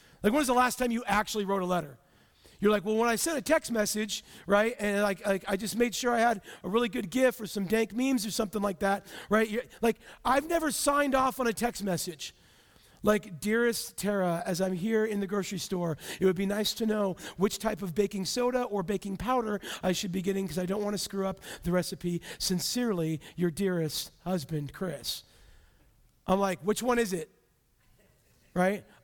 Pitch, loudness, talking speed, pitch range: 205 Hz, -30 LUFS, 210 wpm, 185-230 Hz